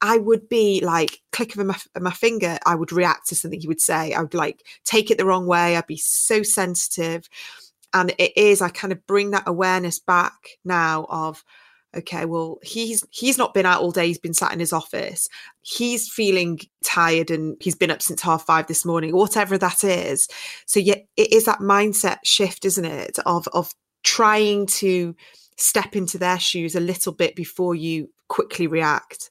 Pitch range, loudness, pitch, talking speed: 170-210 Hz, -20 LUFS, 180 Hz, 195 wpm